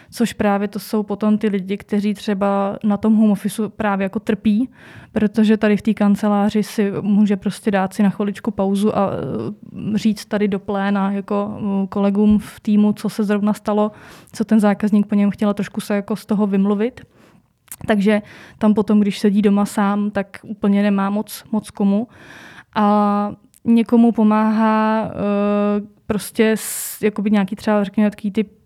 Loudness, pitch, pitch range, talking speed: -18 LUFS, 210 Hz, 205-215 Hz, 160 wpm